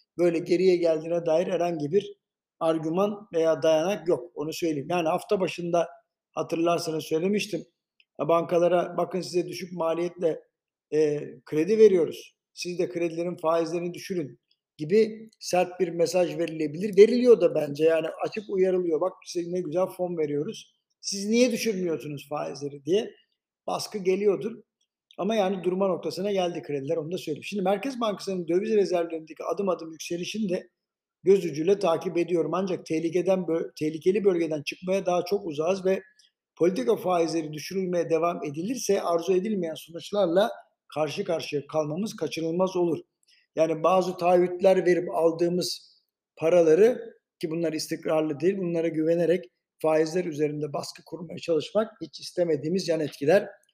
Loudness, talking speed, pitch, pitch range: -26 LUFS, 130 wpm, 175 Hz, 160-195 Hz